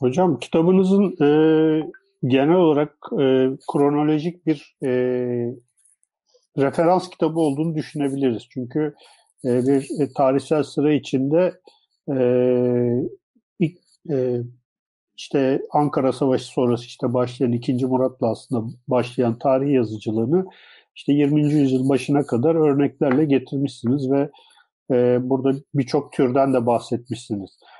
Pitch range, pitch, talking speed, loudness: 125-155 Hz, 135 Hz, 105 wpm, -21 LUFS